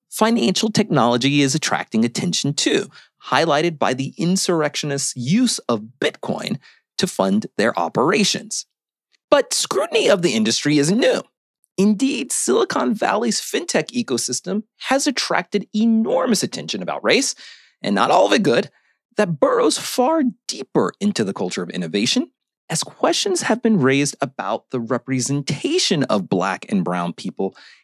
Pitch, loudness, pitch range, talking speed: 200 Hz, -19 LUFS, 140-230 Hz, 135 wpm